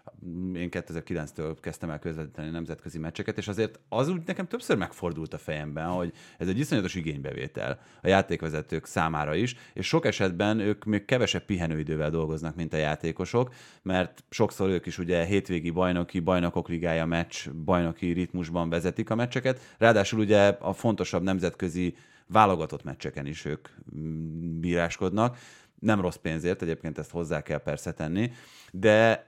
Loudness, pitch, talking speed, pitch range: -28 LUFS, 90 Hz, 145 wpm, 80-100 Hz